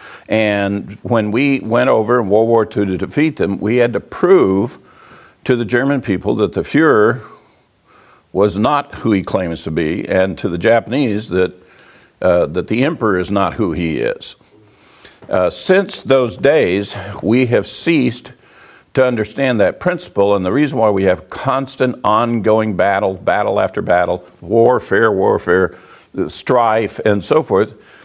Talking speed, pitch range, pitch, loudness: 155 wpm, 100-130 Hz, 110 Hz, -15 LUFS